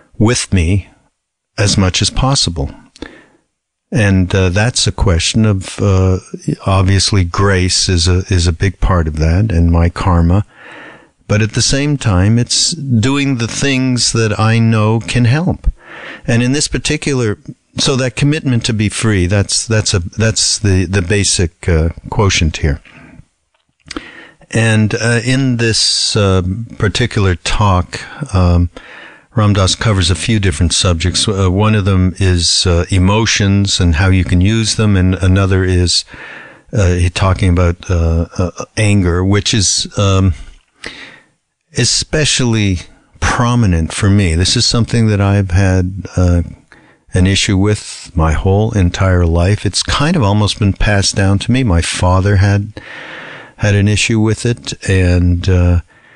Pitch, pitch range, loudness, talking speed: 100 Hz, 90-110 Hz, -13 LUFS, 145 wpm